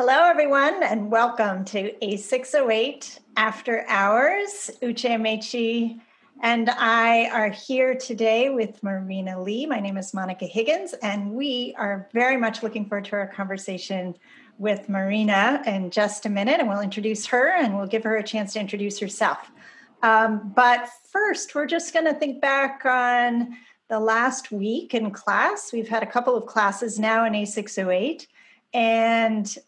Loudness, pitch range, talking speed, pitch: -23 LUFS, 210-250 Hz, 170 wpm, 225 Hz